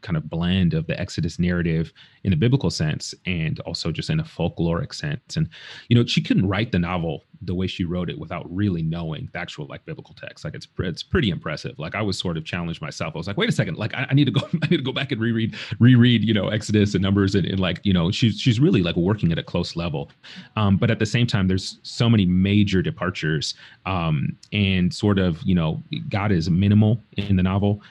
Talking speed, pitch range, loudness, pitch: 245 wpm, 90-120 Hz, -22 LUFS, 100 Hz